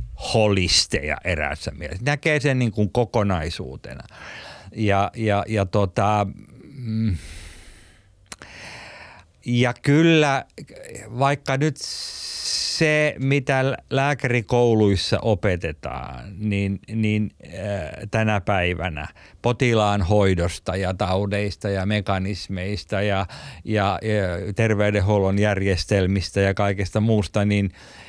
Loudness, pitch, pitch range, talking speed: -22 LUFS, 105 Hz, 95-110 Hz, 85 wpm